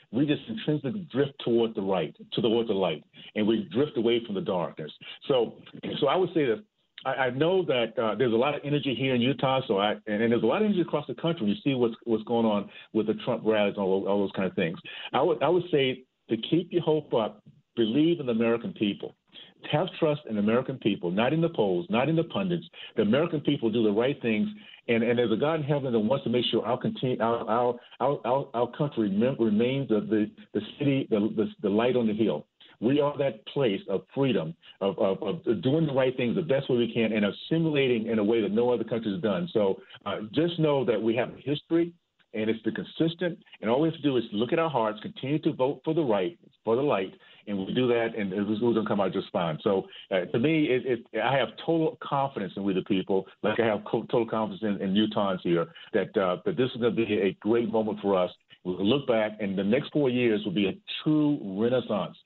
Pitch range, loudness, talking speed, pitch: 110-150 Hz, -27 LUFS, 250 wpm, 120 Hz